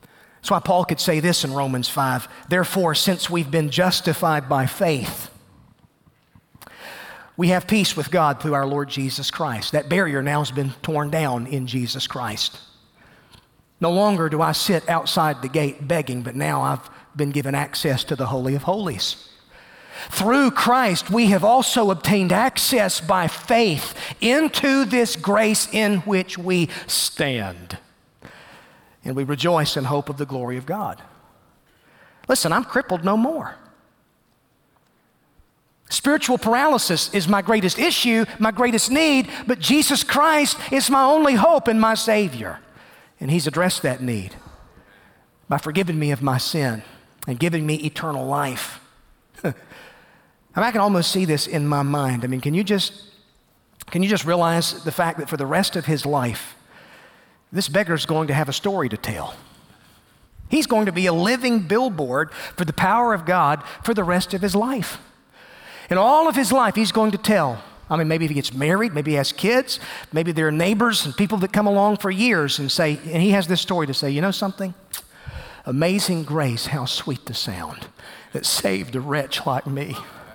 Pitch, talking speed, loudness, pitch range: 170 Hz, 175 wpm, -20 LUFS, 145-205 Hz